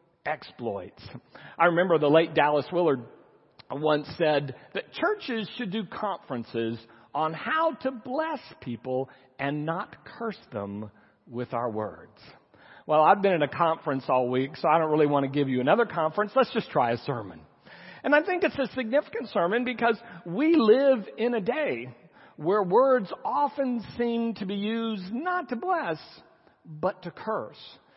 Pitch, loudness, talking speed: 180 Hz, -27 LUFS, 160 wpm